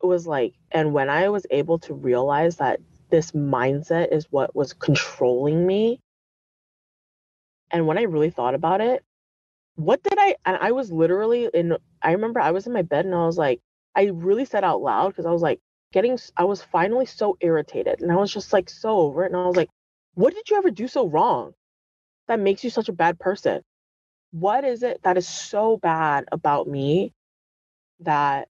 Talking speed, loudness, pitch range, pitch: 200 wpm, -22 LUFS, 155-215 Hz, 175 Hz